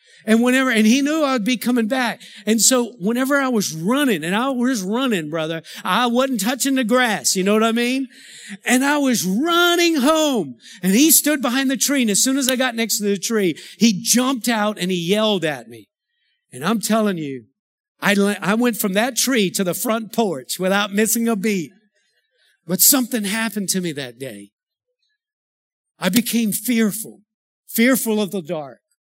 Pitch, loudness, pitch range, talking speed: 225 Hz, -18 LUFS, 200-260 Hz, 185 wpm